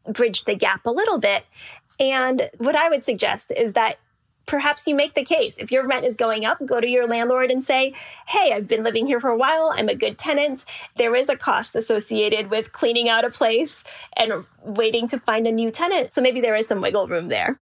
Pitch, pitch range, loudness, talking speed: 255 Hz, 230-295 Hz, -21 LUFS, 225 wpm